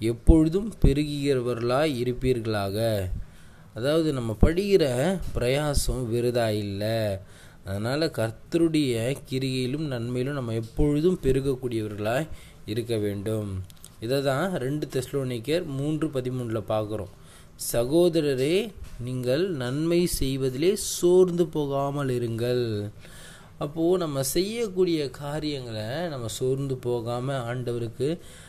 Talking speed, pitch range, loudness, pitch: 80 wpm, 115-150 Hz, -26 LUFS, 130 Hz